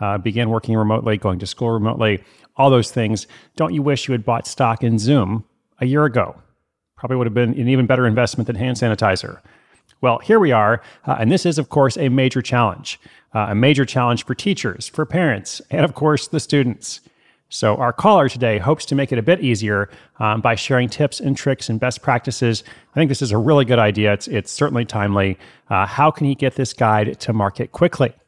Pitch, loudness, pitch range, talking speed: 120 Hz, -18 LUFS, 110-140 Hz, 215 wpm